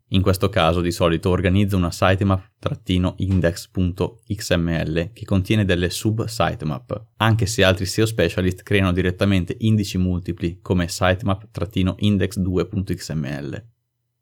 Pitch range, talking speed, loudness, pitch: 90-105 Hz, 95 wpm, -21 LUFS, 95 Hz